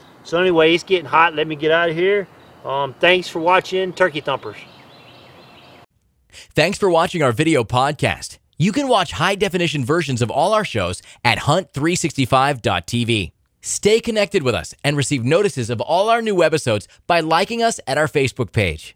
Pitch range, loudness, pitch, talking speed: 125-180 Hz, -18 LUFS, 155 Hz, 170 wpm